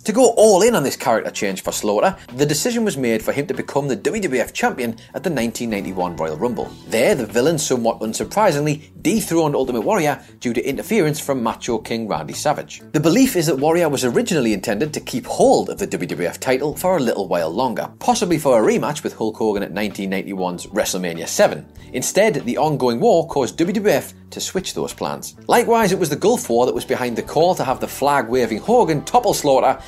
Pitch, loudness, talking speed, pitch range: 130 Hz, -19 LUFS, 205 wpm, 115-160 Hz